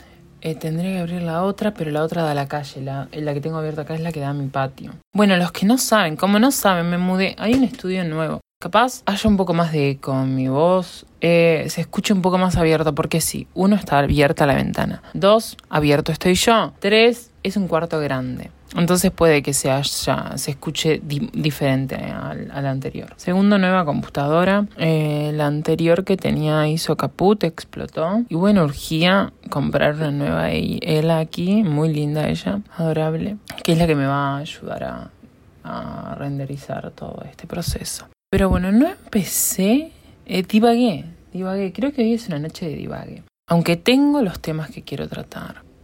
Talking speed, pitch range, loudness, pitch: 190 wpm, 150-195 Hz, -20 LUFS, 165 Hz